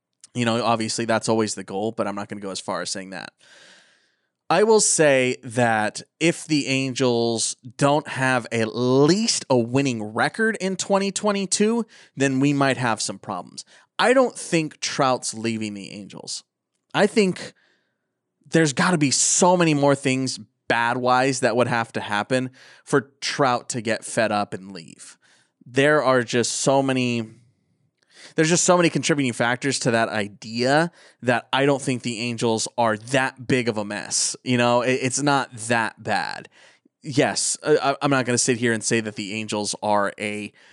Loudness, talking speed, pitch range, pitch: -21 LUFS, 175 wpm, 115-145 Hz, 125 Hz